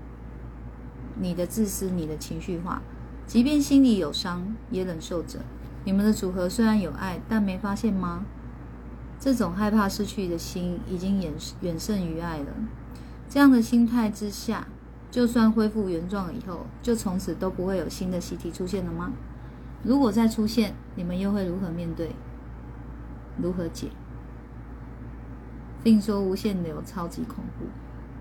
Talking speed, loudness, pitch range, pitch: 220 characters per minute, -26 LUFS, 170-215 Hz, 190 Hz